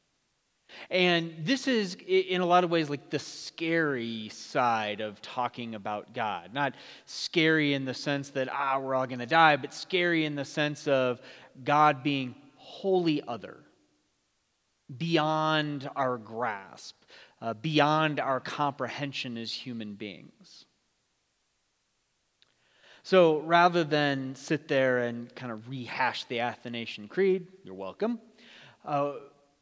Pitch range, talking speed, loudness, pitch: 125-160 Hz, 130 wpm, -28 LUFS, 145 Hz